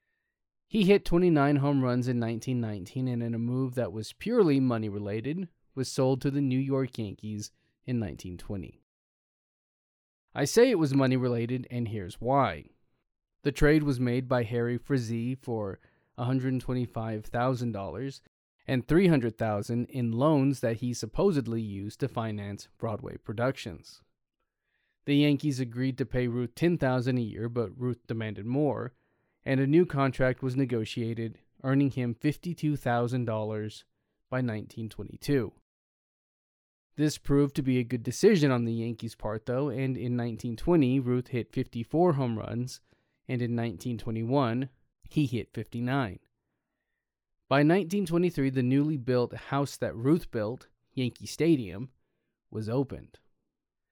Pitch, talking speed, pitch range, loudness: 125 Hz, 130 wpm, 115-140 Hz, -29 LUFS